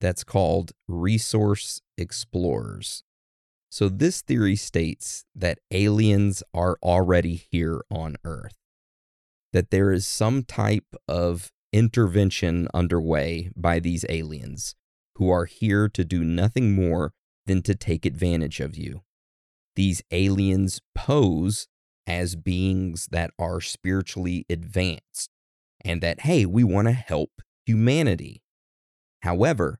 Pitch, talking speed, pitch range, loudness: 90 Hz, 115 wpm, 85-100 Hz, -24 LUFS